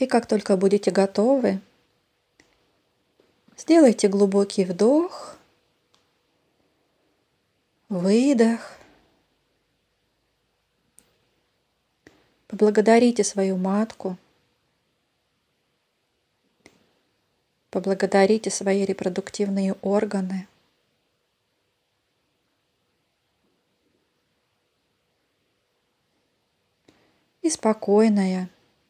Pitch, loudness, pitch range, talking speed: 205 Hz, -21 LUFS, 195-225 Hz, 35 wpm